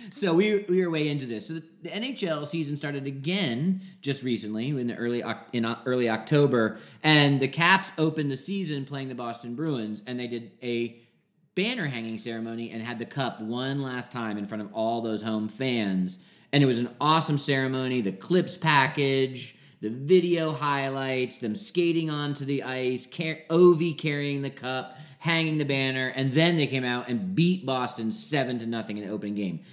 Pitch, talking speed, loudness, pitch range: 135 Hz, 190 wpm, -27 LUFS, 120-160 Hz